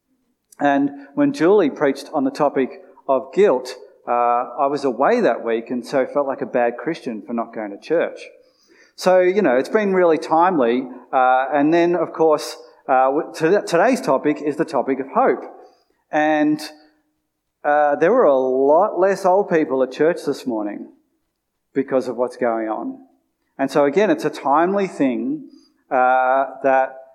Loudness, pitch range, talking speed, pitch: -19 LUFS, 130-190 Hz, 165 wpm, 150 Hz